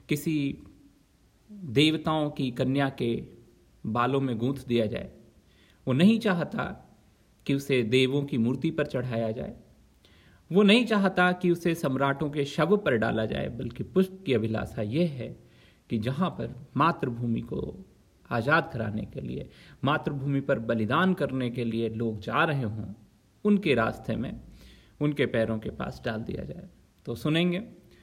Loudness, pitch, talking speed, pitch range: -28 LUFS, 135 Hz, 150 wpm, 115-160 Hz